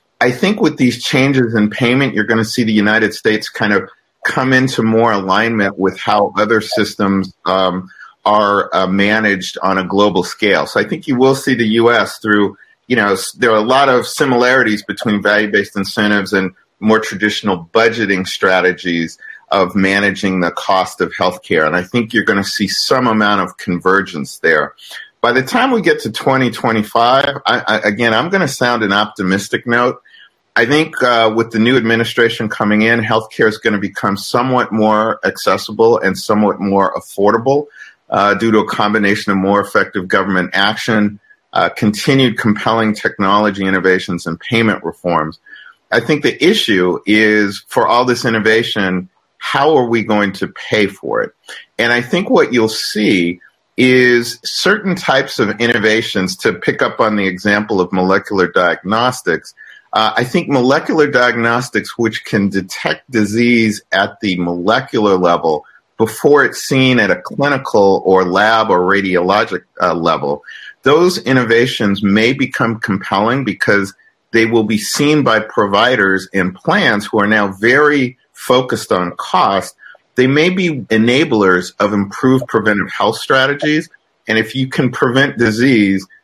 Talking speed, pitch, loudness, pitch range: 160 wpm, 110 Hz, -13 LUFS, 100-120 Hz